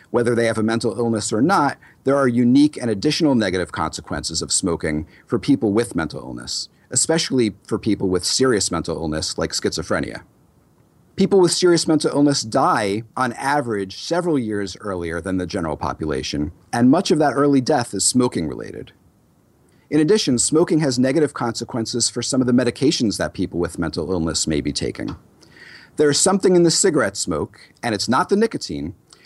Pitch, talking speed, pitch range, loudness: 120 Hz, 175 wpm, 95-145 Hz, -19 LUFS